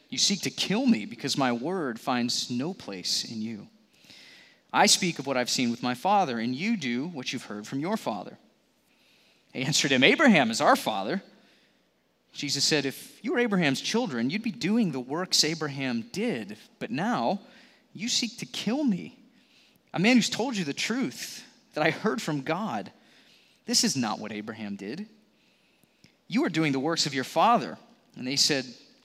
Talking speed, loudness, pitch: 180 wpm, -27 LUFS, 185 Hz